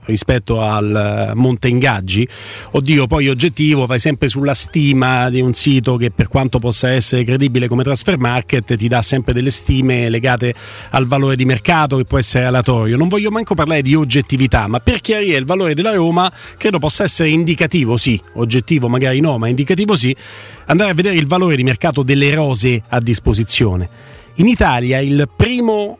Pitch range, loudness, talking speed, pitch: 120-155 Hz, -14 LUFS, 175 wpm, 130 Hz